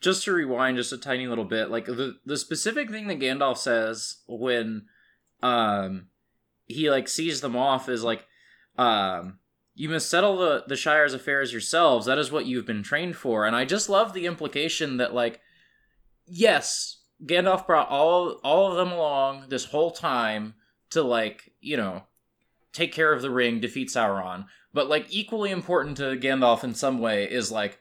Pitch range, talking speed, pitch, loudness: 115-160 Hz, 175 wpm, 135 Hz, -25 LUFS